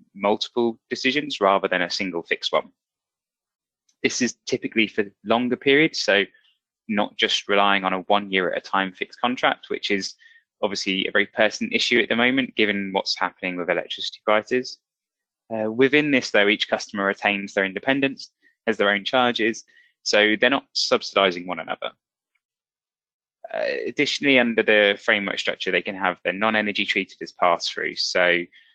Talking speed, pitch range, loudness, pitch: 165 wpm, 95-125 Hz, -22 LUFS, 105 Hz